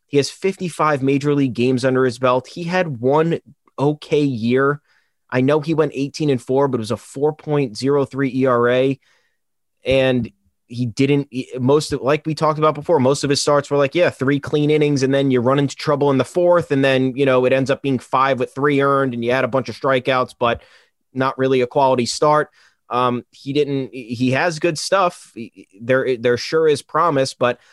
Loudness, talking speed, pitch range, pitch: -18 LUFS, 205 wpm, 130-145 Hz, 135 Hz